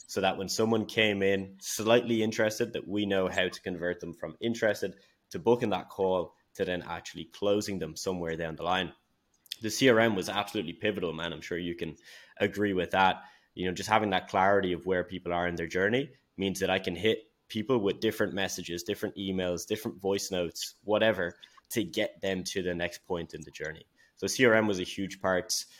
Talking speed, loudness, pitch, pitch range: 200 wpm, -30 LUFS, 95 Hz, 90-110 Hz